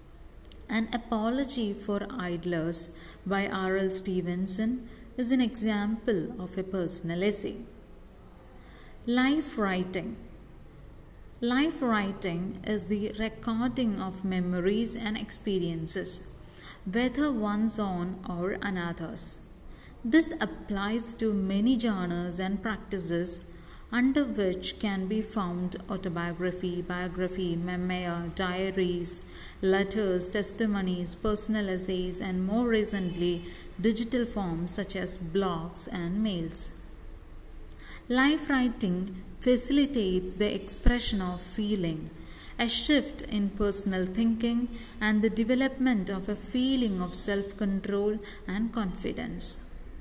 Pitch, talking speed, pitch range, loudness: 200 Hz, 100 wpm, 180-225 Hz, -29 LUFS